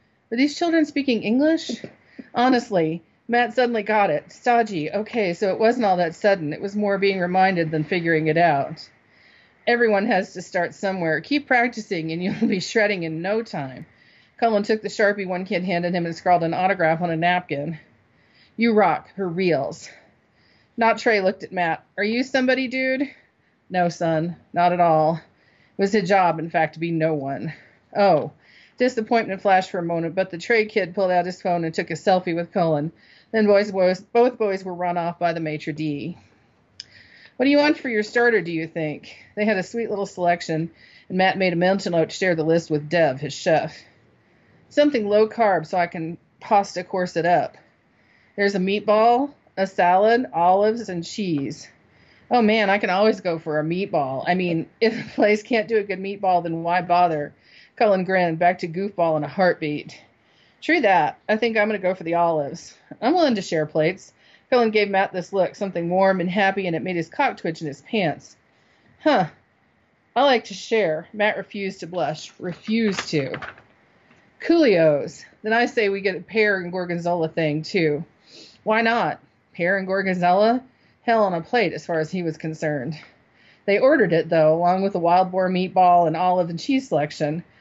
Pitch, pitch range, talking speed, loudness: 185 Hz, 170-215 Hz, 190 wpm, -21 LUFS